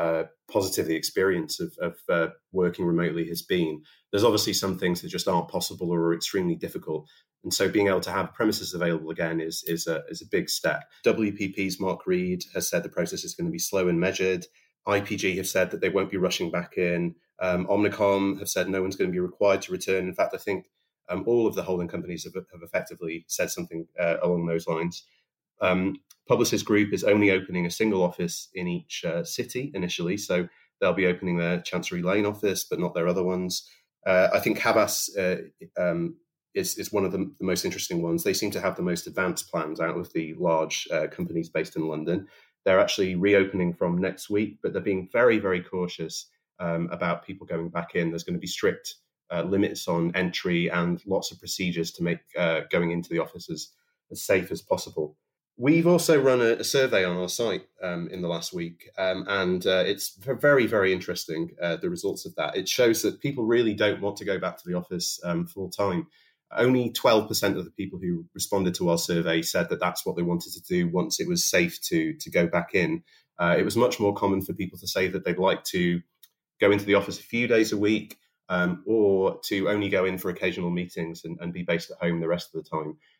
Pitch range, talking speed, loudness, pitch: 85-105 Hz, 220 wpm, -26 LUFS, 90 Hz